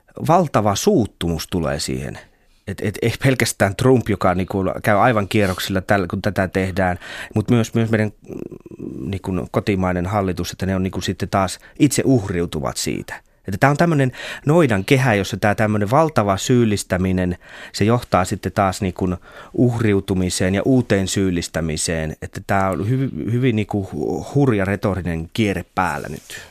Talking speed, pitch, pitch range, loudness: 145 wpm, 100 Hz, 95-115 Hz, -19 LUFS